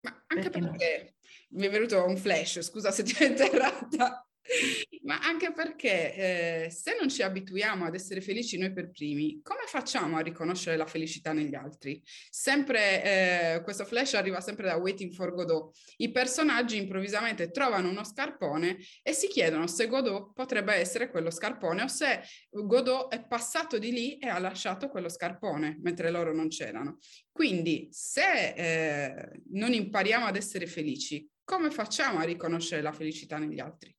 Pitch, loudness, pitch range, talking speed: 195 Hz, -30 LUFS, 170-250 Hz, 160 wpm